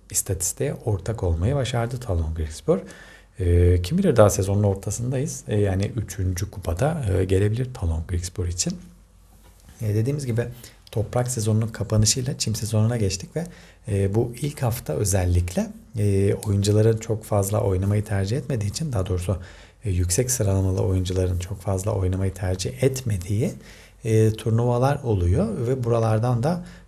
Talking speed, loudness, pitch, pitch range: 120 wpm, -24 LUFS, 105 Hz, 95-120 Hz